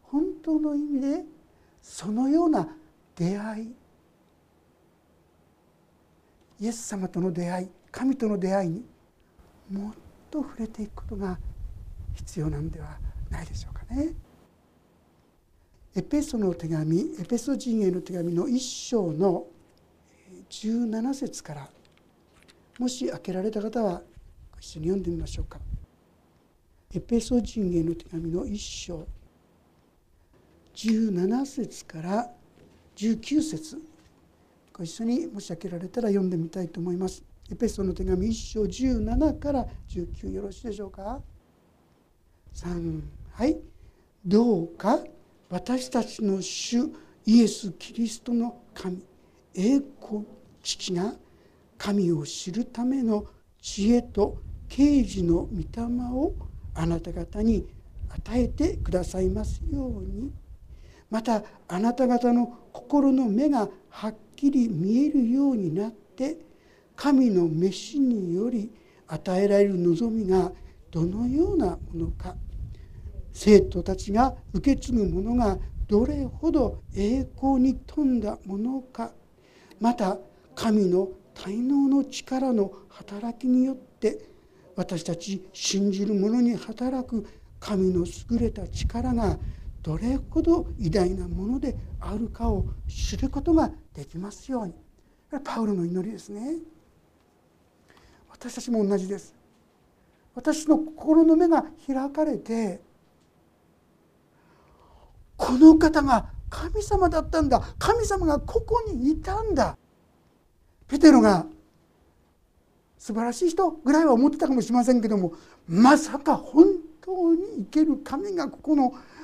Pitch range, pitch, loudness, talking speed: 185-270 Hz, 220 Hz, -26 LUFS, 215 characters per minute